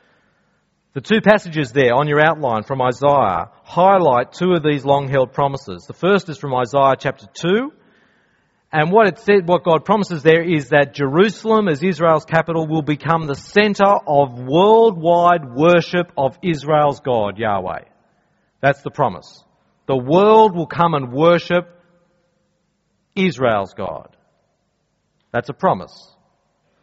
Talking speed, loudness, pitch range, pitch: 135 wpm, -16 LUFS, 140-180 Hz, 165 Hz